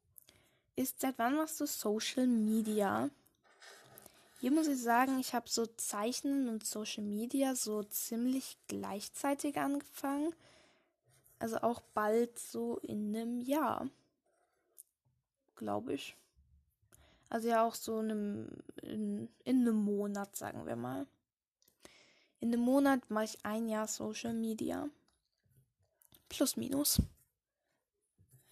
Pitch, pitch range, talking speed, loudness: 230 Hz, 210-275 Hz, 115 wpm, -36 LUFS